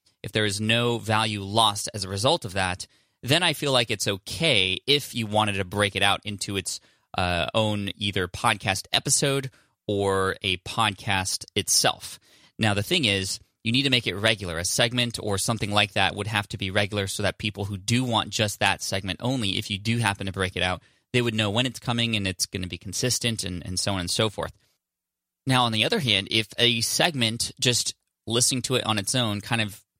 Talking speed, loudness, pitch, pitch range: 220 wpm, -24 LUFS, 105 Hz, 100-115 Hz